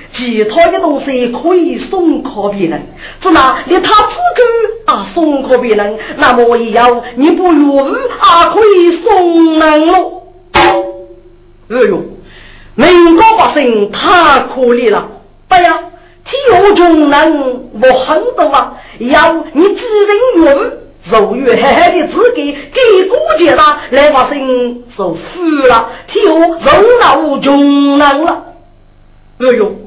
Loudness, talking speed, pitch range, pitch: -8 LUFS, 180 characters per minute, 255-360 Hz, 320 Hz